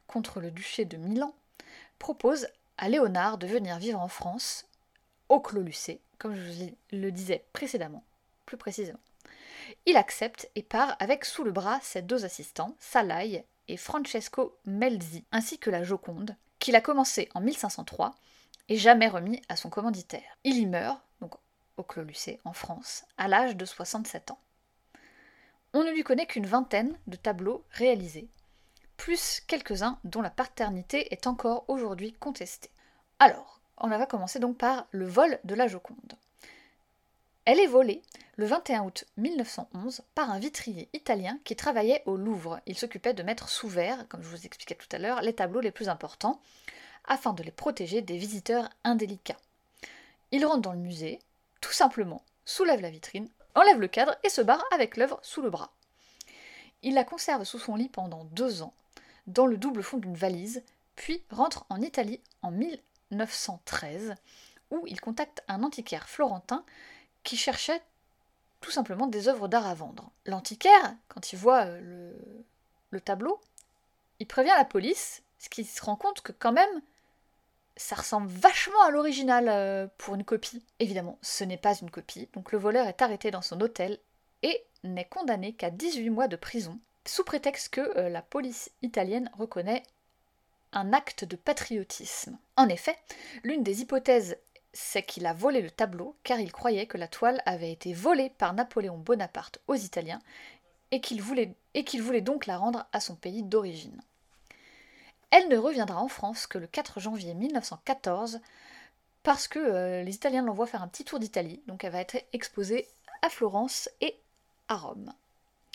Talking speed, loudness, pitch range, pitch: 165 wpm, -29 LUFS, 195-265 Hz, 230 Hz